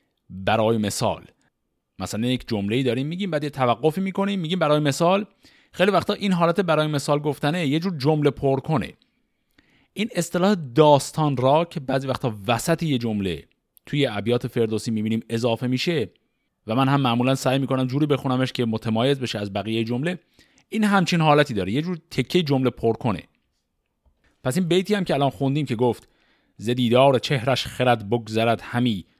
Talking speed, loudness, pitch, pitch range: 165 wpm, -22 LUFS, 135 Hz, 120-155 Hz